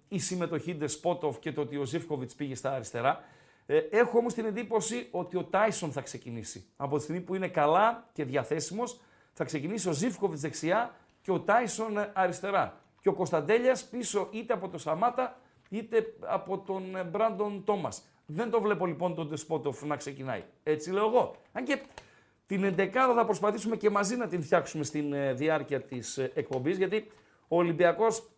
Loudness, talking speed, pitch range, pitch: -31 LUFS, 170 wpm, 150-220 Hz, 185 Hz